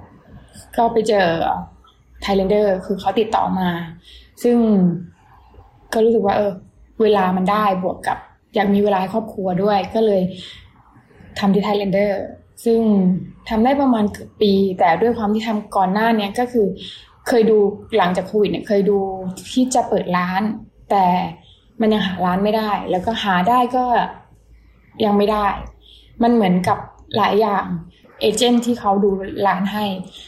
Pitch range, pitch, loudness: 190-220 Hz, 205 Hz, -18 LUFS